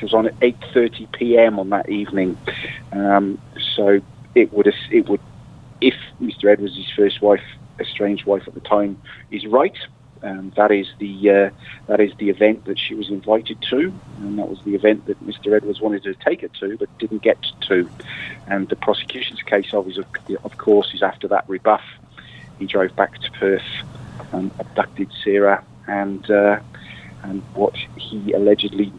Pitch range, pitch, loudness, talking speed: 100-110 Hz, 105 Hz, -19 LUFS, 175 wpm